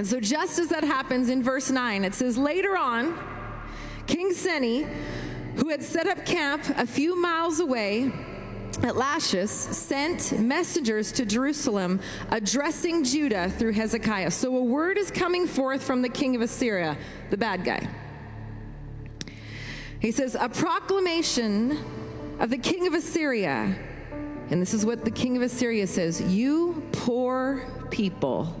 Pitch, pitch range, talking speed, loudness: 255 Hz, 220-310 Hz, 145 wpm, -26 LUFS